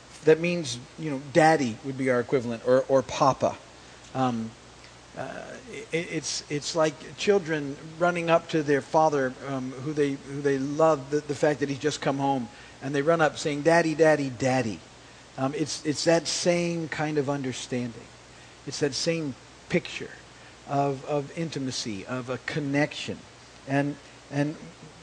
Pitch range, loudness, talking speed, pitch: 130-155 Hz, -27 LUFS, 160 wpm, 140 Hz